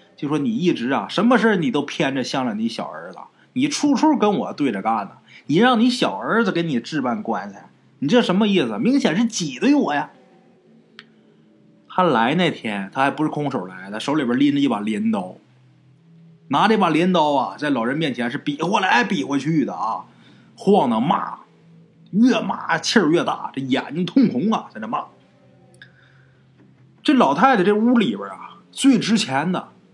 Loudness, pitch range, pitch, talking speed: -20 LUFS, 160-245 Hz, 210 Hz, 250 characters per minute